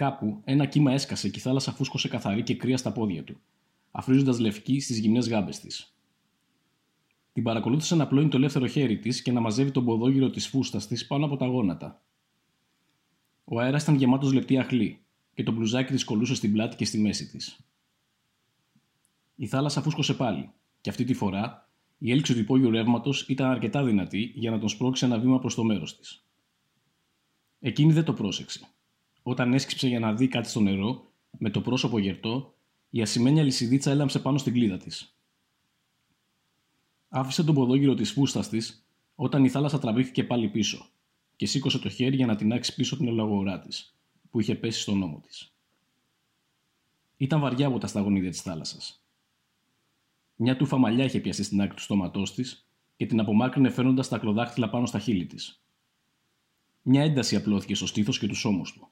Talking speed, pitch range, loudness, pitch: 175 wpm, 110-135 Hz, -26 LUFS, 125 Hz